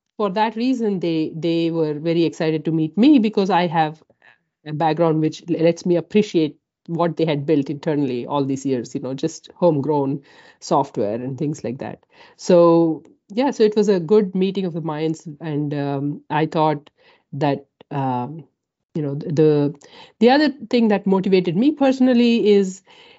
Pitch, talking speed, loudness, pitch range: 165 Hz, 170 wpm, -19 LUFS, 150-200 Hz